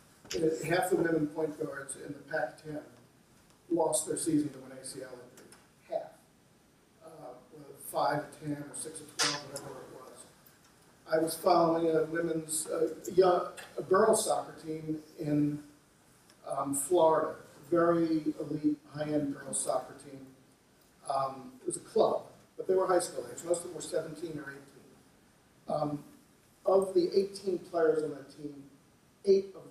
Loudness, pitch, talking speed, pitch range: -32 LUFS, 155 Hz, 155 wpm, 145-170 Hz